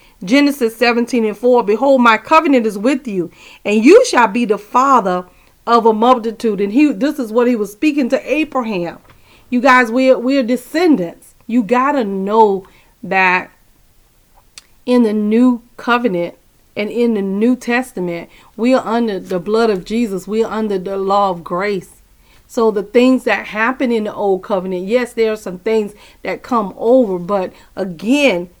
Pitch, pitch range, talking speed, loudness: 230 Hz, 200-250 Hz, 165 wpm, -15 LUFS